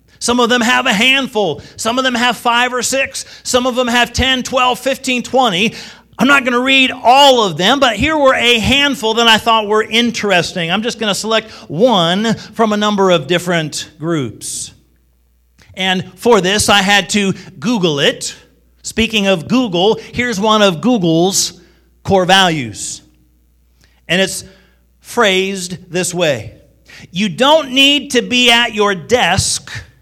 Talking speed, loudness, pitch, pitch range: 160 wpm, -12 LUFS, 210 Hz, 175-245 Hz